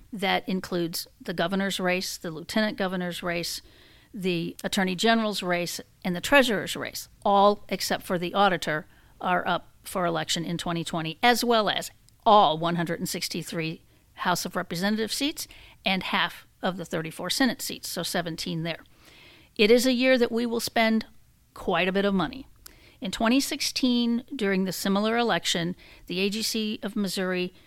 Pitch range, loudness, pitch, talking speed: 175-220 Hz, -26 LUFS, 195 Hz, 150 wpm